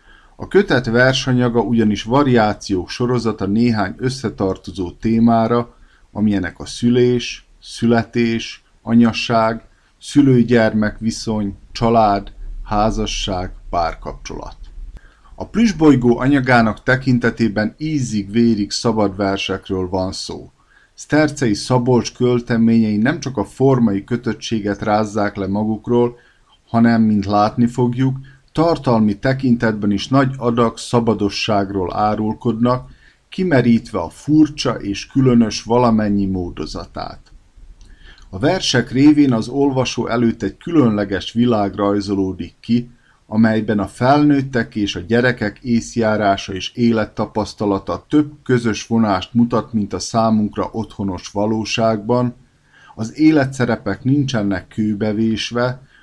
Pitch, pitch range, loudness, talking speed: 115 Hz, 105-125 Hz, -17 LUFS, 95 wpm